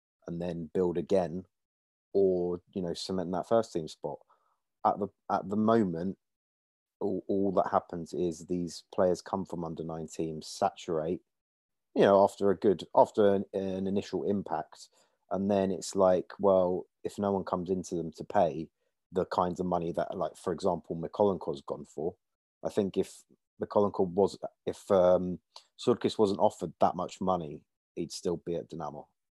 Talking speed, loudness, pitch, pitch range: 170 wpm, -31 LUFS, 90 Hz, 85-95 Hz